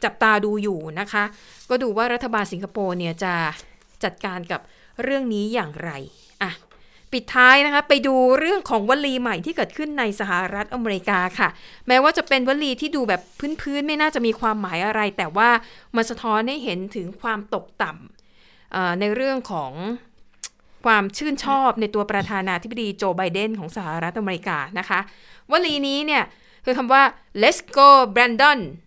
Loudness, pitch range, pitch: -20 LUFS, 195-265 Hz, 225 Hz